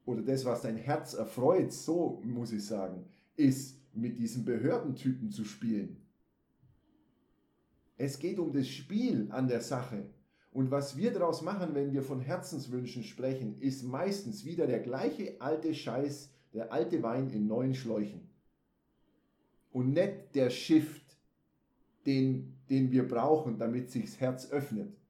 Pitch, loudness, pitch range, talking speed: 130 Hz, -34 LUFS, 120-145 Hz, 145 wpm